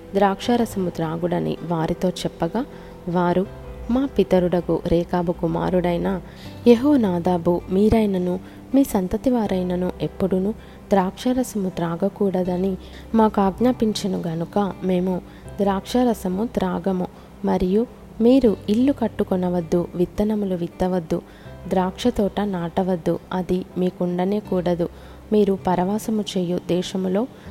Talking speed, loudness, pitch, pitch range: 85 wpm, -22 LUFS, 190 Hz, 180-210 Hz